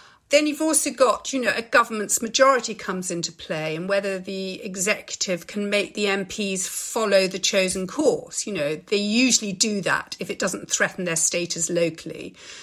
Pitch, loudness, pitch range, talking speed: 200 Hz, -22 LUFS, 185-230 Hz, 175 wpm